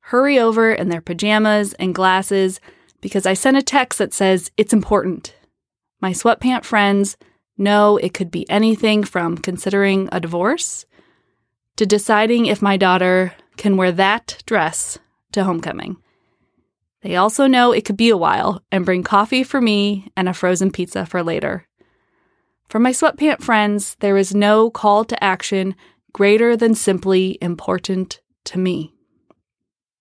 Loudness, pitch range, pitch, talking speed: -17 LUFS, 185-220 Hz, 200 Hz, 150 wpm